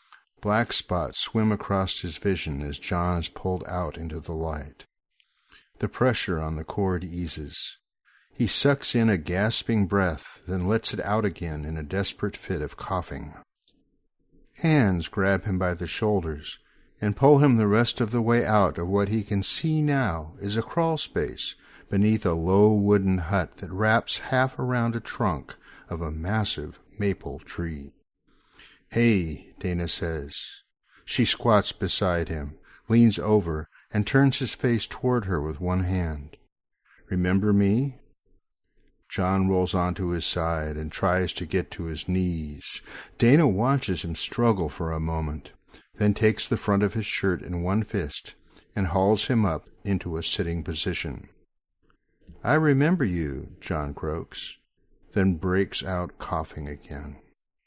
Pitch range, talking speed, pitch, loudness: 85-110 Hz, 150 wpm, 95 Hz, -26 LUFS